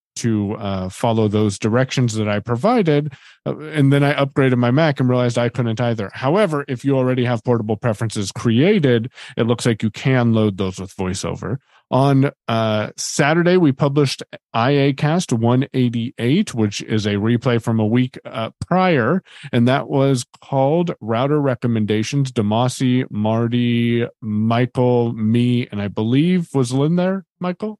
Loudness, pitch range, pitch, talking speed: -18 LUFS, 115-140 Hz, 125 Hz, 150 wpm